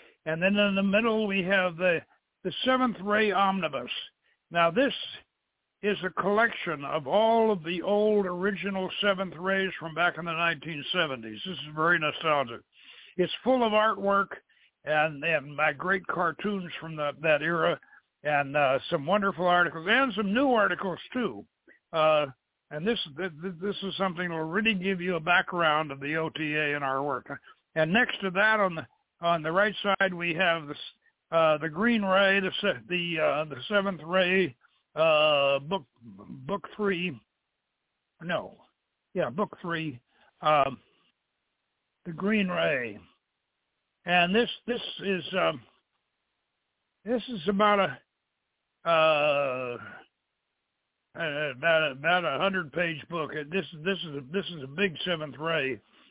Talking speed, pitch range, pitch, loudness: 150 wpm, 155-200 Hz, 180 Hz, -27 LUFS